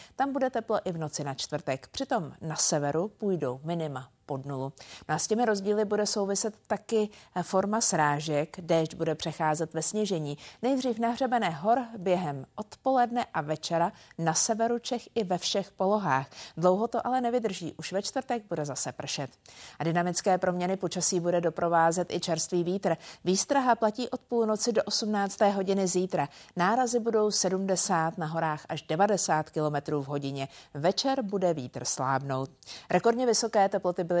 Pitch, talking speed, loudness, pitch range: 180 Hz, 155 wpm, -29 LUFS, 155-215 Hz